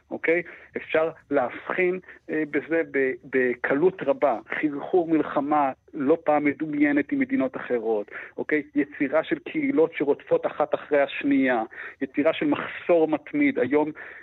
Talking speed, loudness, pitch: 120 wpm, -25 LUFS, 185 Hz